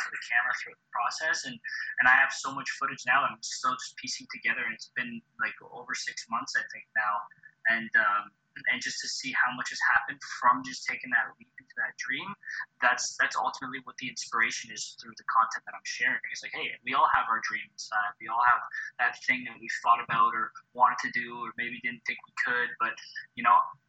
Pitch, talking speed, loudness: 275 Hz, 230 wpm, -29 LUFS